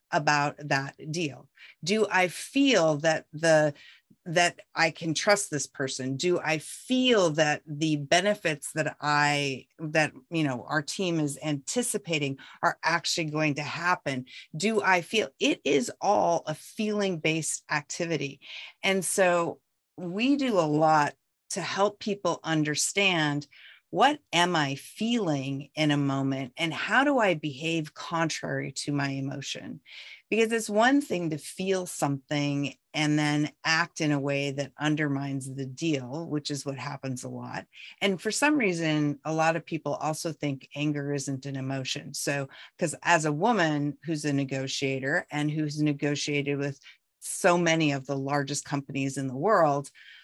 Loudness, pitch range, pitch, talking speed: -27 LUFS, 140-175 Hz, 150 Hz, 155 wpm